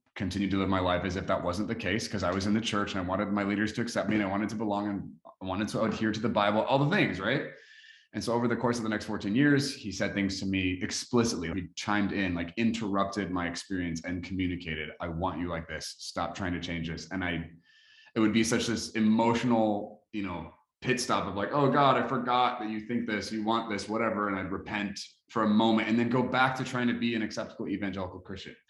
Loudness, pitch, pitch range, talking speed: -30 LUFS, 105 Hz, 95-115 Hz, 255 wpm